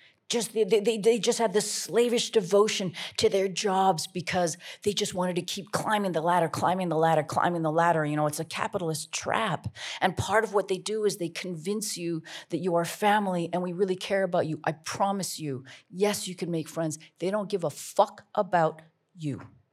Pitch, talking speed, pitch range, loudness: 185 Hz, 205 wpm, 165-205 Hz, -28 LUFS